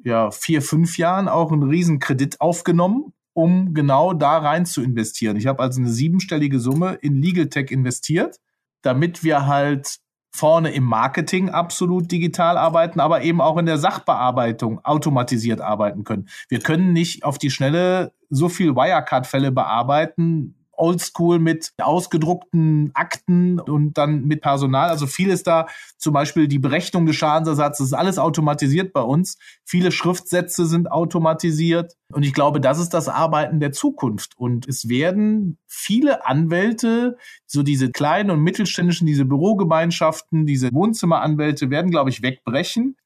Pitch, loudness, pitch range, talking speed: 160 Hz, -19 LUFS, 140-175 Hz, 150 wpm